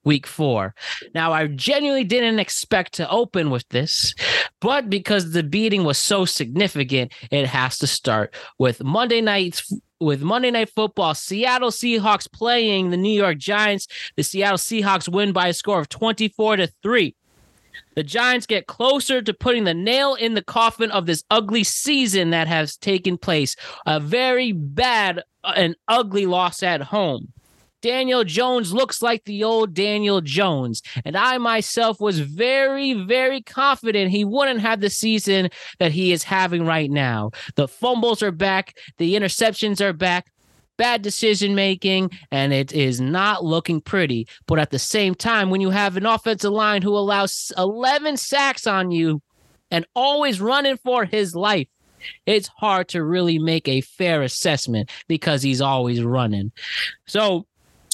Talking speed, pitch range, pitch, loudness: 160 wpm, 160-225 Hz, 195 Hz, -20 LUFS